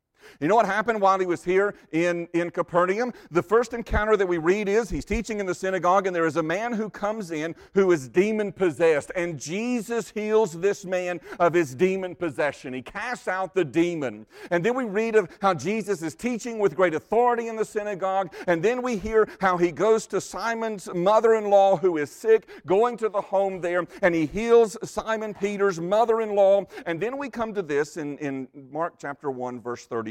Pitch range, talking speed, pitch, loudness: 170-215 Hz, 200 wpm, 190 Hz, -24 LUFS